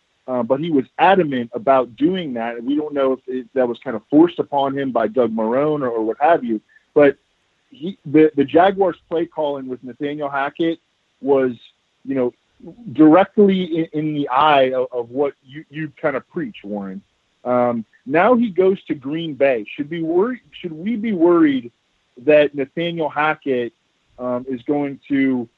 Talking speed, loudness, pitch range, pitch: 180 wpm, -19 LUFS, 125-165 Hz, 140 Hz